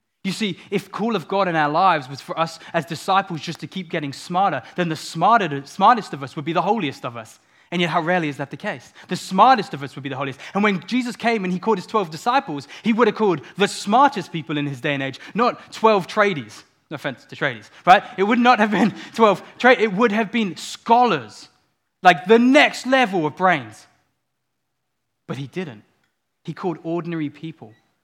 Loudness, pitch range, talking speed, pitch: -20 LUFS, 145-210 Hz, 220 wpm, 180 Hz